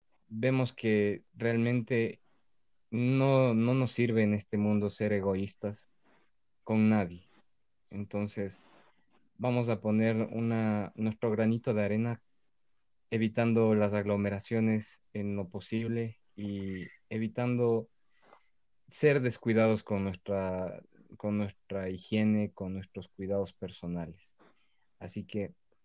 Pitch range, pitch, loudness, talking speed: 100-115 Hz, 105 Hz, -31 LUFS, 100 wpm